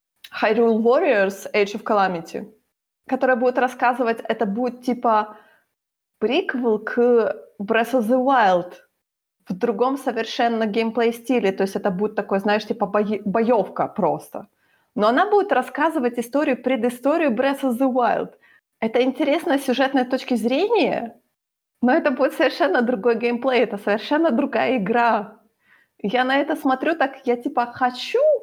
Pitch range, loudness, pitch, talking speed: 225-265 Hz, -21 LUFS, 245 Hz, 135 wpm